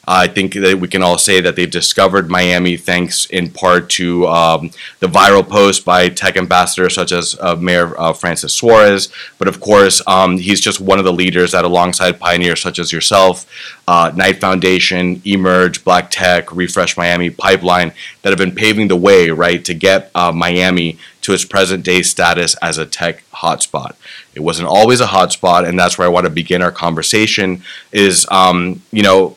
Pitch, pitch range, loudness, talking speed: 90 Hz, 85-95 Hz, -11 LUFS, 185 wpm